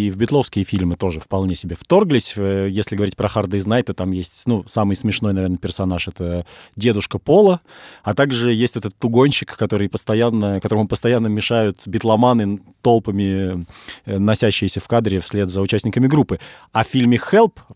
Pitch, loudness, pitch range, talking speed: 105 Hz, -18 LUFS, 95-120 Hz, 160 wpm